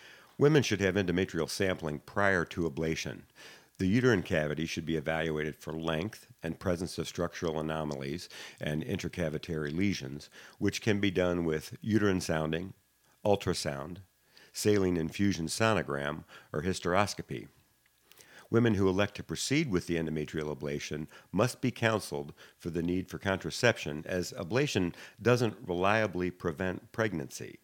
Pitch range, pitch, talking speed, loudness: 80-100 Hz, 90 Hz, 130 wpm, -32 LUFS